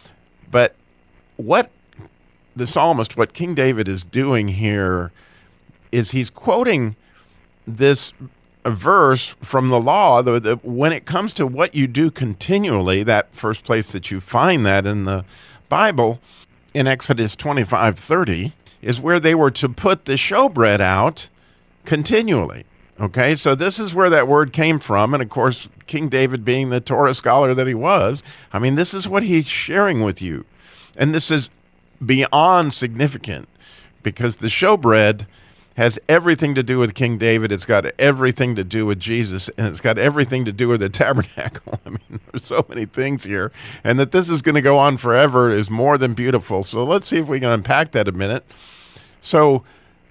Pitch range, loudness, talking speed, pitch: 110-145 Hz, -17 LUFS, 170 wpm, 125 Hz